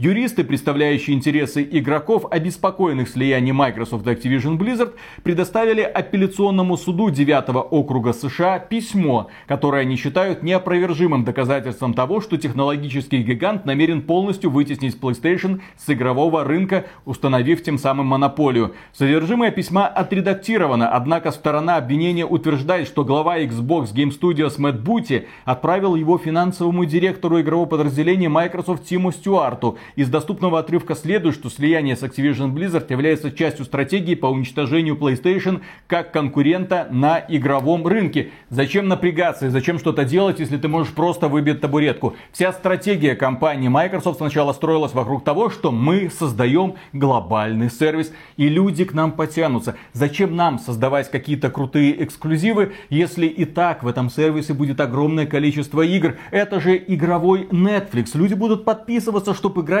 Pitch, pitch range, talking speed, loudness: 155 Hz, 140-180 Hz, 135 wpm, -19 LUFS